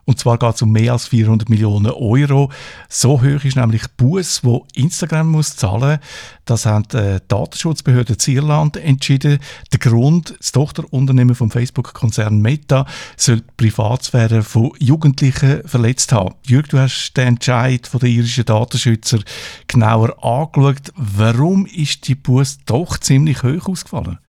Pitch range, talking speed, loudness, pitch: 115-140 Hz, 150 wpm, -15 LUFS, 130 Hz